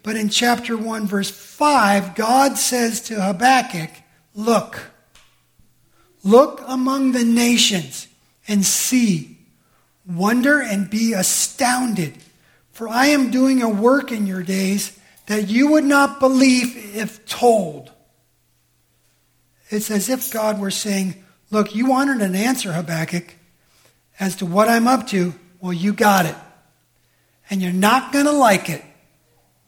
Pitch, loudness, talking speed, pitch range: 210 Hz, -18 LUFS, 135 wpm, 185-250 Hz